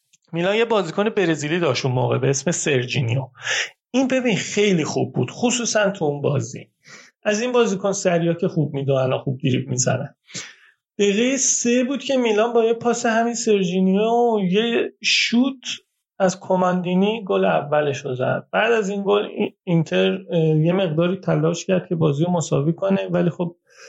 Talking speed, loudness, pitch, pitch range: 160 wpm, -20 LUFS, 190 Hz, 165-225 Hz